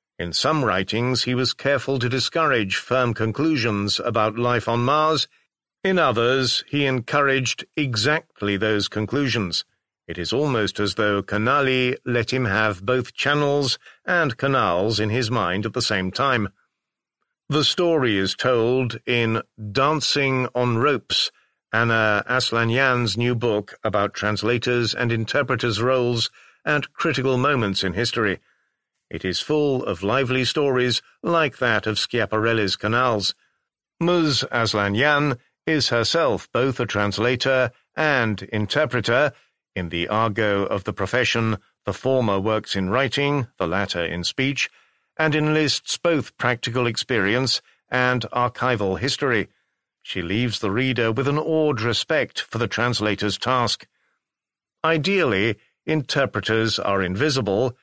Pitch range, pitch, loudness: 105-135 Hz, 120 Hz, -21 LUFS